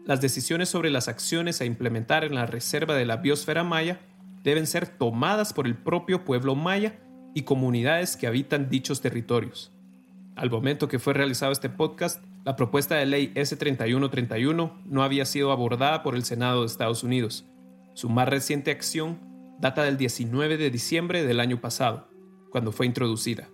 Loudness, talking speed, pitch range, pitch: -26 LUFS, 165 wpm, 120-160 Hz, 140 Hz